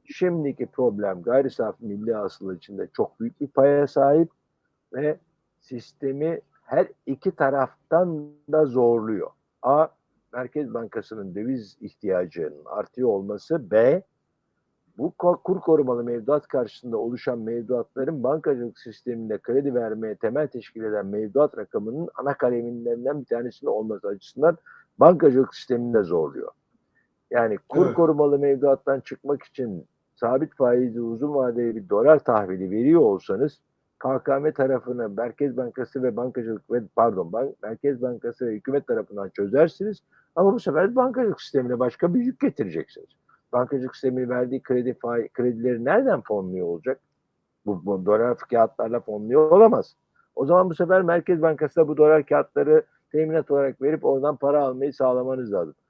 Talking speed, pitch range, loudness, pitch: 130 wpm, 120-155 Hz, -23 LUFS, 130 Hz